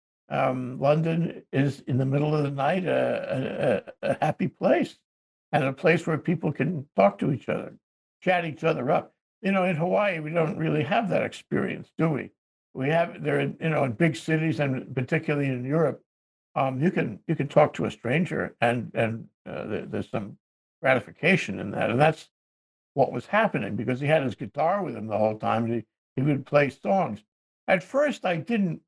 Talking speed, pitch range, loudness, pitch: 195 wpm, 130-165 Hz, -26 LUFS, 145 Hz